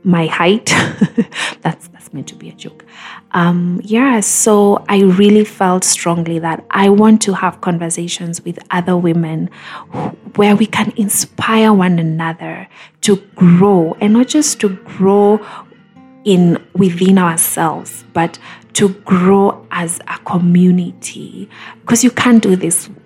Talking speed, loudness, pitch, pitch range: 140 wpm, -13 LUFS, 190 Hz, 175-210 Hz